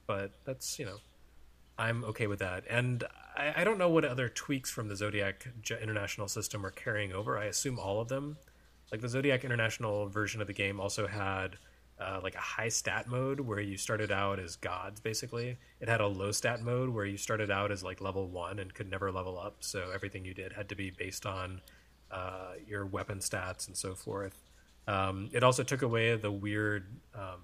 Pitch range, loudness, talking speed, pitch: 95-115 Hz, -35 LUFS, 210 wpm, 100 Hz